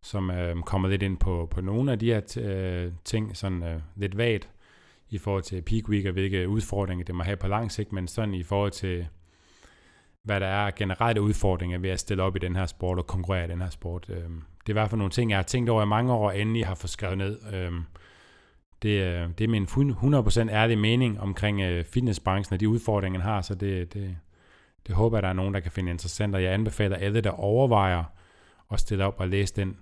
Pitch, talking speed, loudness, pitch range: 100 Hz, 235 wpm, -27 LUFS, 90-105 Hz